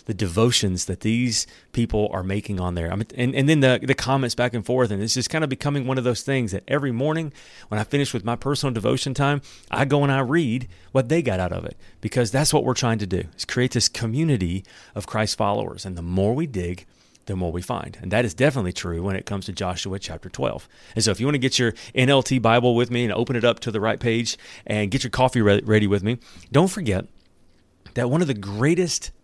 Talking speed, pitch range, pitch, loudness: 250 wpm, 100-130 Hz, 115 Hz, -23 LUFS